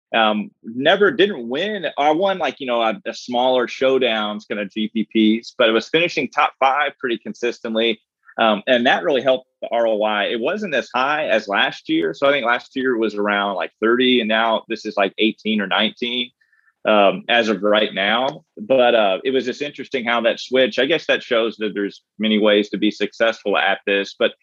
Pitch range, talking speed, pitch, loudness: 105-125 Hz, 205 wpm, 115 Hz, -19 LUFS